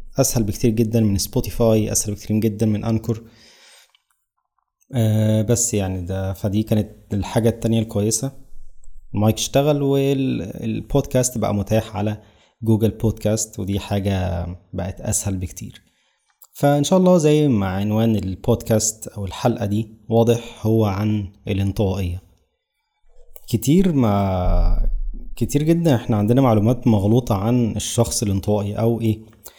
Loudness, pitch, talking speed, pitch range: -20 LUFS, 110 Hz, 120 wpm, 100-120 Hz